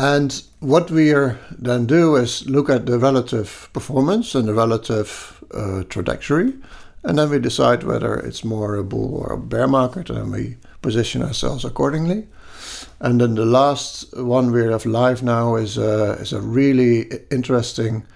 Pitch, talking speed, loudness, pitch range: 125 Hz, 160 wpm, -19 LUFS, 110-135 Hz